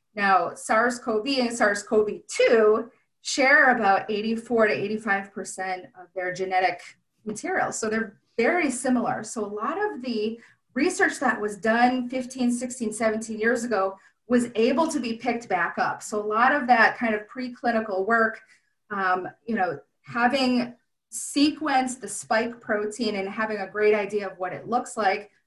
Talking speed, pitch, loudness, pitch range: 155 wpm, 225 Hz, -24 LUFS, 210-250 Hz